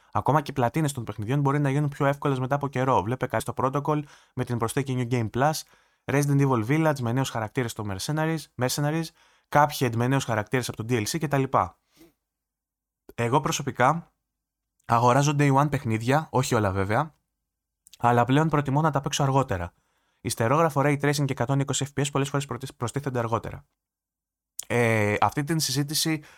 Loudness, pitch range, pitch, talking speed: -25 LUFS, 115-145 Hz, 130 Hz, 160 wpm